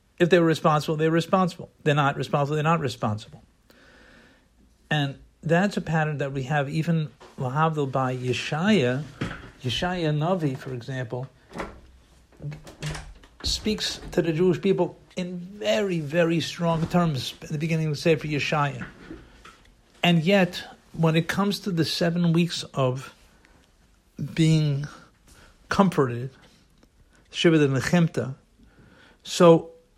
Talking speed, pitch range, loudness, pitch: 120 wpm, 130-170 Hz, -24 LUFS, 155 Hz